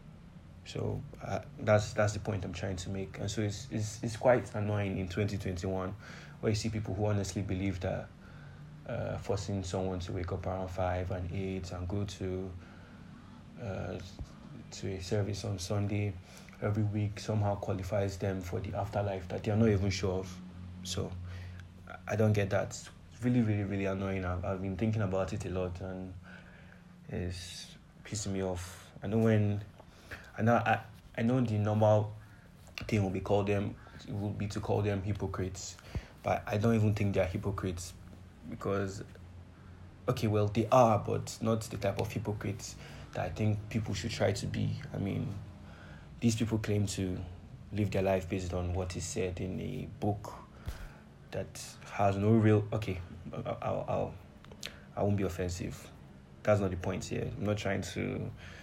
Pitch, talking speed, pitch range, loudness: 100 Hz, 170 wpm, 95-110 Hz, -34 LUFS